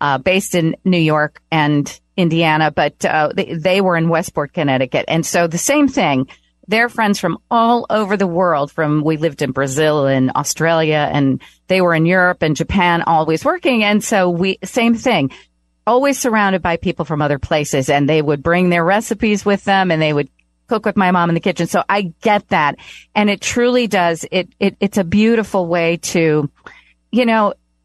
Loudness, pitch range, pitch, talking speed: -16 LUFS, 155-200 Hz, 175 Hz, 195 wpm